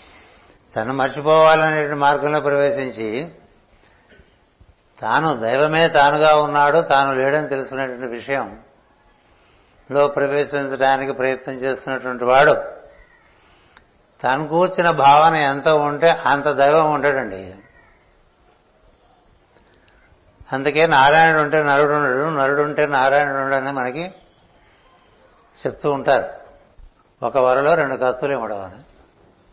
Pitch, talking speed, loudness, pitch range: 140 Hz, 85 wpm, -17 LUFS, 130-150 Hz